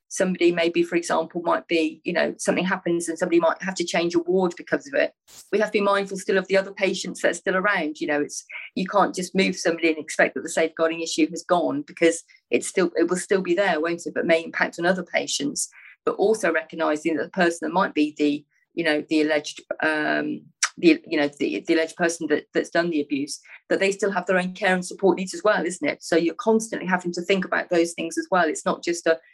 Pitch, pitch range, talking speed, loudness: 175 Hz, 165-190 Hz, 250 wpm, -23 LUFS